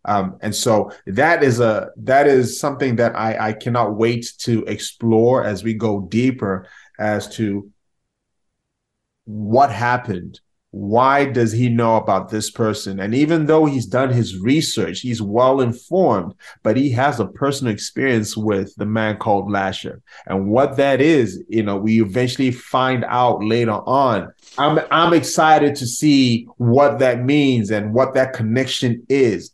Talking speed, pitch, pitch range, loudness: 155 wpm, 120 Hz, 105-130 Hz, -18 LUFS